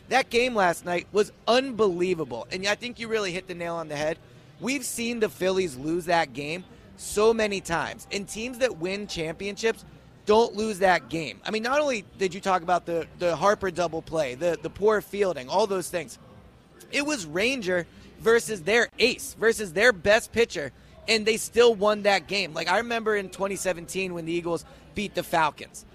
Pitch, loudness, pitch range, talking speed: 195 Hz, -26 LUFS, 170-220 Hz, 195 wpm